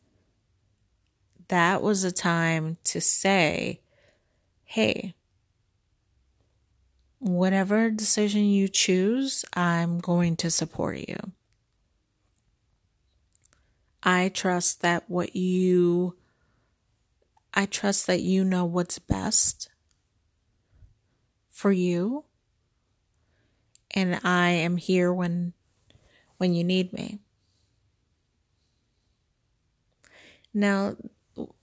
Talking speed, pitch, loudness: 75 wpm, 170 Hz, -25 LUFS